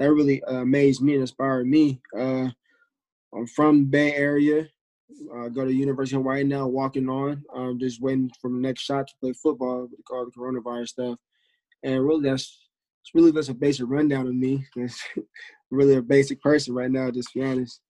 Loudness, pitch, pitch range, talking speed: -24 LUFS, 135 Hz, 125-145 Hz, 190 wpm